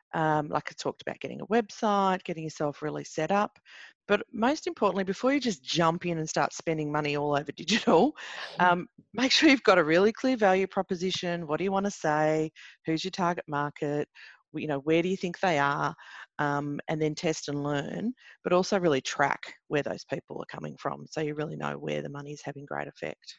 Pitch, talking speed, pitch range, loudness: 170 Hz, 215 wpm, 150-200 Hz, -28 LUFS